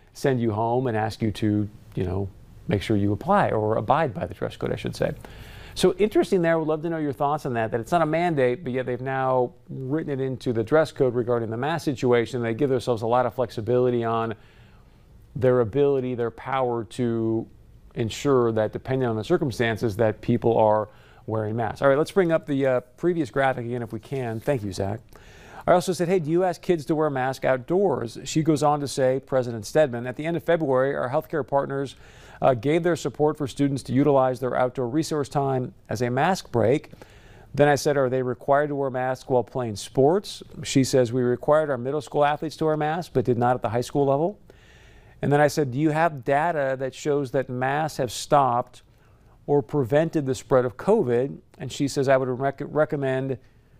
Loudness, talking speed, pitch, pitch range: -24 LUFS, 215 wpm, 130 Hz, 120-145 Hz